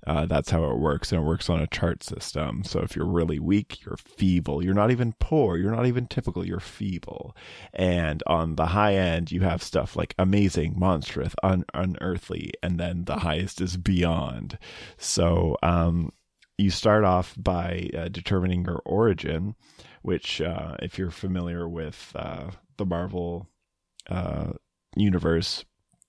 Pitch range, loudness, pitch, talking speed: 85-95 Hz, -26 LUFS, 90 Hz, 160 wpm